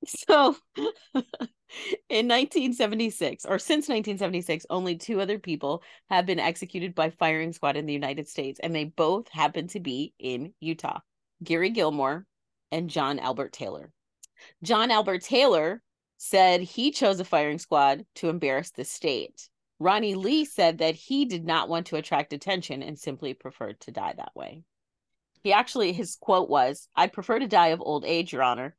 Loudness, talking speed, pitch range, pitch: -26 LUFS, 165 wpm, 155-215 Hz, 175 Hz